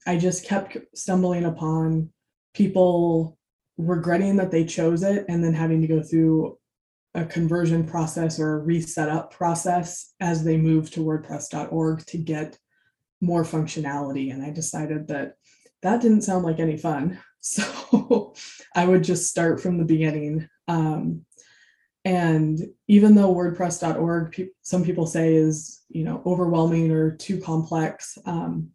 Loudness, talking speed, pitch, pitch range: -23 LUFS, 145 wpm, 165 Hz, 160-180 Hz